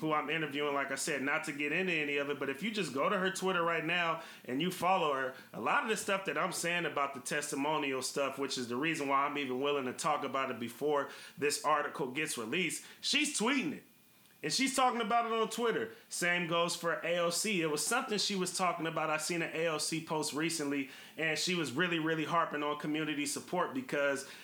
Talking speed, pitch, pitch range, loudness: 230 wpm, 160 Hz, 145-180 Hz, -33 LUFS